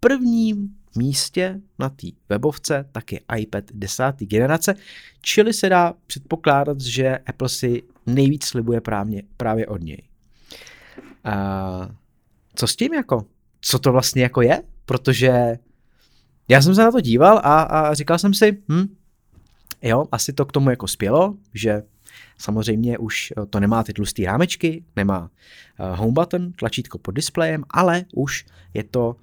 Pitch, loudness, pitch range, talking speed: 130 Hz, -20 LUFS, 110-160 Hz, 145 wpm